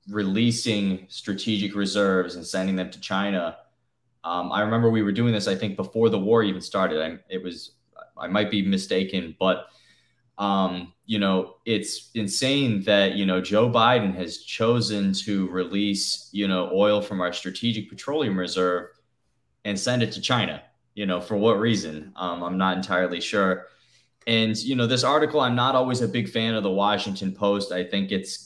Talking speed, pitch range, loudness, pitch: 180 wpm, 95-115 Hz, -24 LUFS, 100 Hz